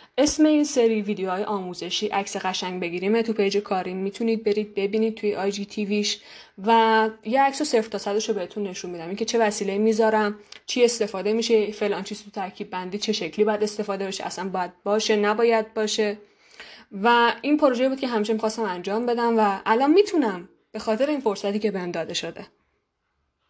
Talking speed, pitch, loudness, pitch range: 180 wpm, 210 Hz, -23 LUFS, 195-225 Hz